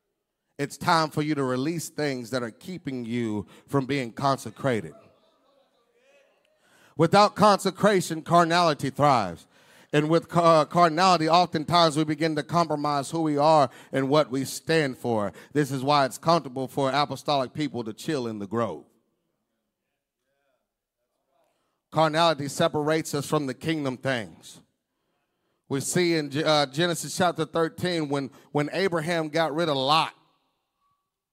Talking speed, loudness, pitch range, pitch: 130 wpm, -25 LUFS, 135-165 Hz, 150 Hz